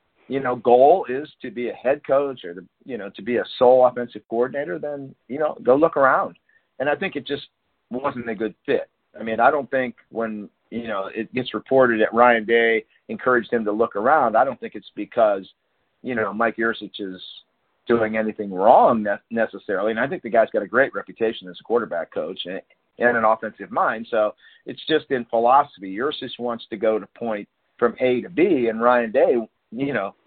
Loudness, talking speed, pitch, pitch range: -21 LUFS, 205 wpm, 115 Hz, 110-130 Hz